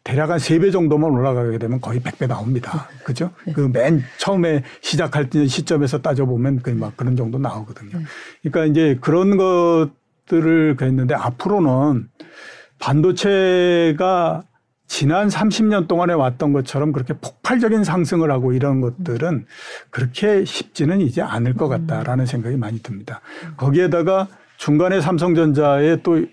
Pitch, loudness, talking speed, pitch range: 150 Hz, -18 LUFS, 315 characters per minute, 130-175 Hz